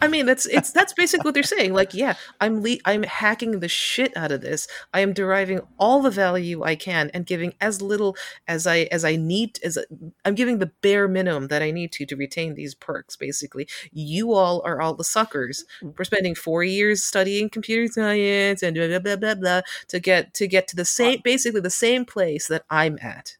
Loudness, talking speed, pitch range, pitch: -22 LUFS, 220 wpm, 170-215 Hz, 190 Hz